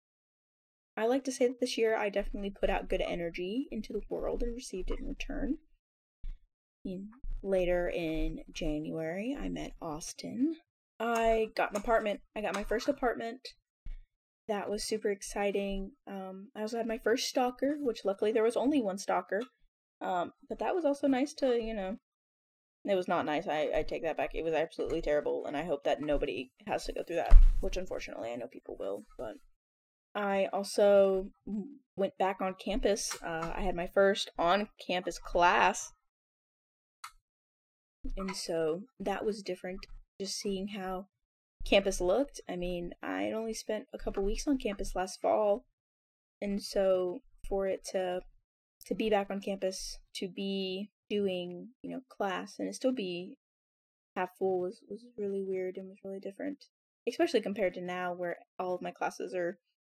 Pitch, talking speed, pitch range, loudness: 200 Hz, 170 wpm, 185-225 Hz, -34 LUFS